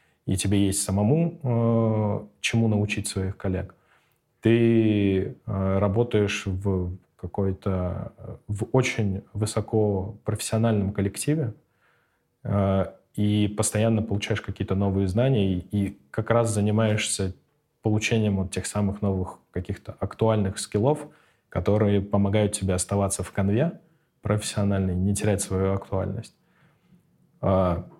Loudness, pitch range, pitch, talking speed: -25 LUFS, 95-110 Hz, 105 Hz, 105 wpm